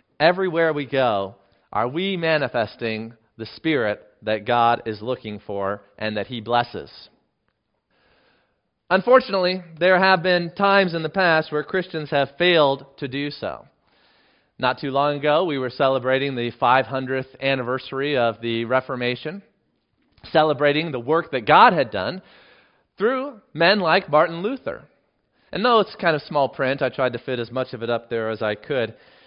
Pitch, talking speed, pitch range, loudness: 135 Hz, 160 wpm, 120-165 Hz, -21 LUFS